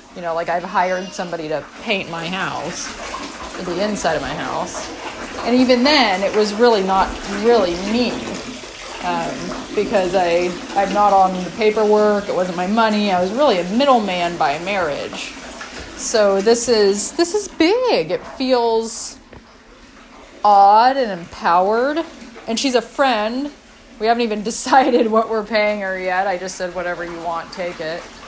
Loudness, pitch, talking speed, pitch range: -18 LUFS, 210 Hz, 160 wpm, 185-245 Hz